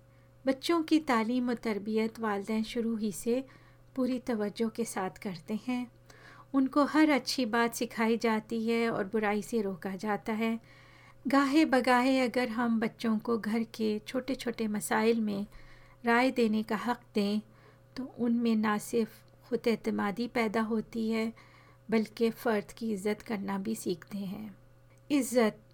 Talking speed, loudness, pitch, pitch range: 145 wpm, -31 LUFS, 230 Hz, 215-245 Hz